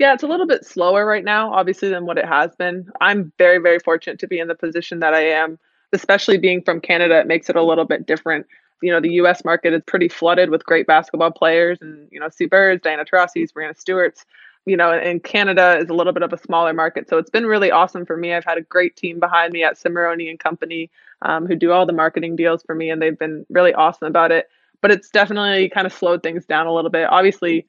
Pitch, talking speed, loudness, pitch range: 170 Hz, 250 wpm, -17 LUFS, 165-180 Hz